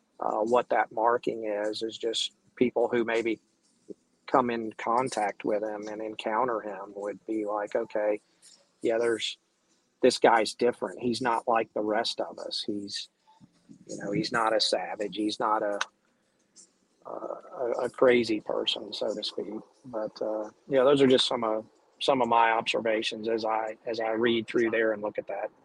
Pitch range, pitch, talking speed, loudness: 105-120 Hz, 110 Hz, 175 wpm, -28 LUFS